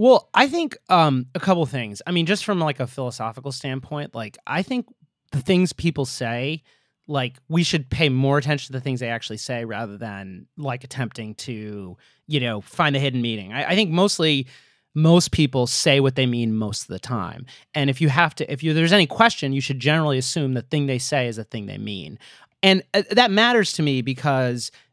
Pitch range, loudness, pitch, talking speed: 120-165 Hz, -21 LUFS, 140 Hz, 215 wpm